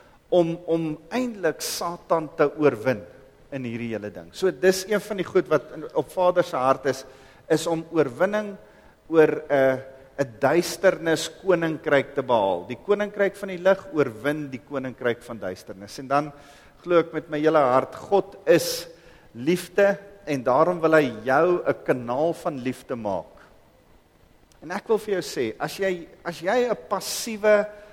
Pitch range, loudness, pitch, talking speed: 135-185 Hz, -24 LUFS, 155 Hz, 165 wpm